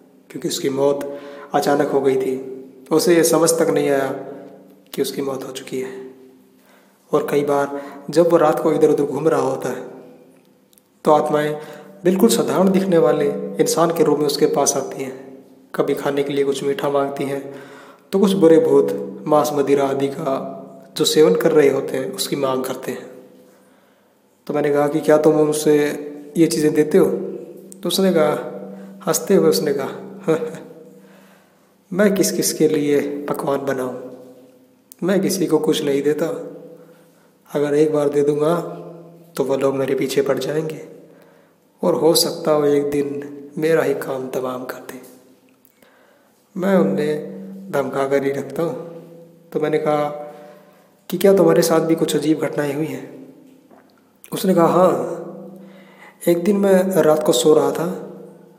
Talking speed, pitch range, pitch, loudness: 160 wpm, 140-165 Hz, 150 Hz, -18 LUFS